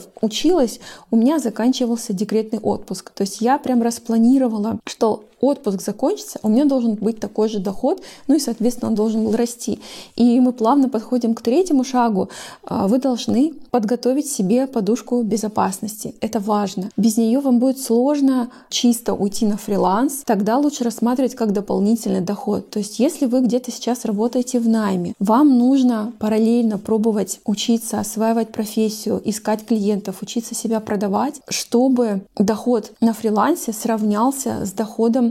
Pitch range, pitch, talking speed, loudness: 215-250 Hz, 230 Hz, 145 wpm, -19 LUFS